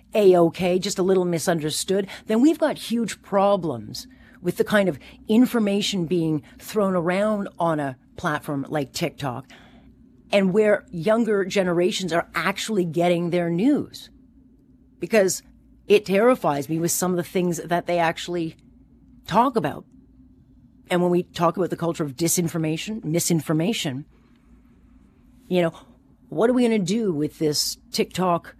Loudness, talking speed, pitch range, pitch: -22 LUFS, 145 wpm, 165-210 Hz, 180 Hz